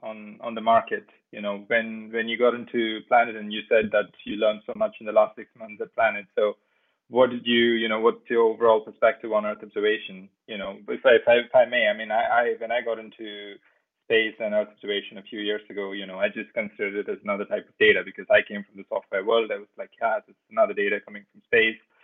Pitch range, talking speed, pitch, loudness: 105-160 Hz, 255 wpm, 115 Hz, -24 LUFS